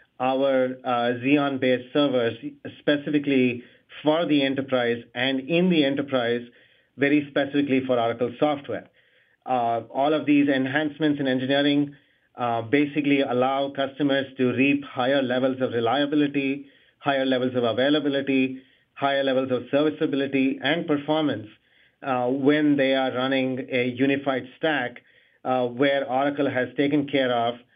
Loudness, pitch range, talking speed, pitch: -24 LUFS, 125-145 Hz, 130 wpm, 135 Hz